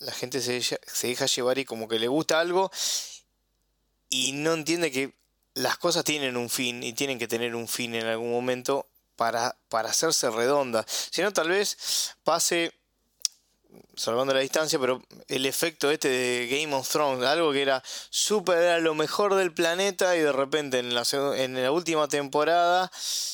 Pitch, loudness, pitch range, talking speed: 140 Hz, -26 LUFS, 125-165 Hz, 175 wpm